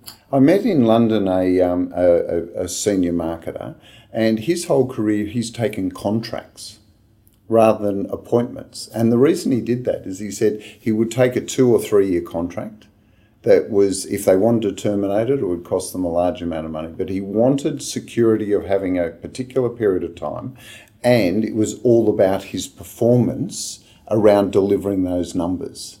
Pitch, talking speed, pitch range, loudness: 105 Hz, 180 wpm, 95-115 Hz, -19 LUFS